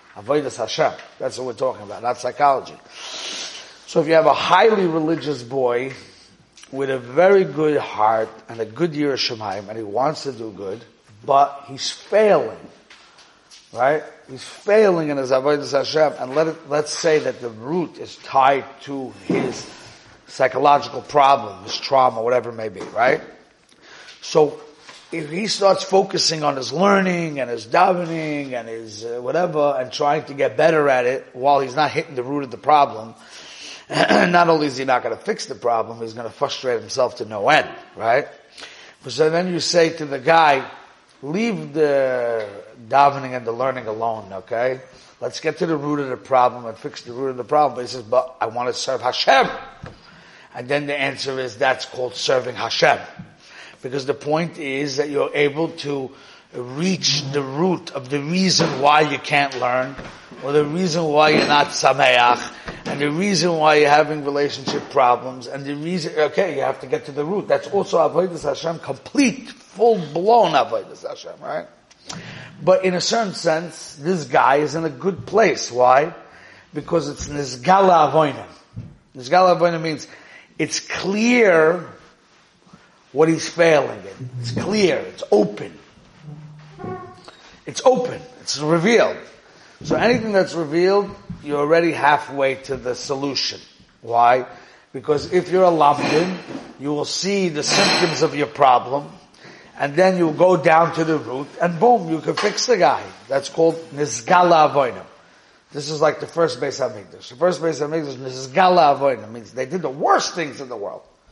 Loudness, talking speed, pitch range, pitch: -19 LUFS, 170 wpm, 130-170 Hz, 150 Hz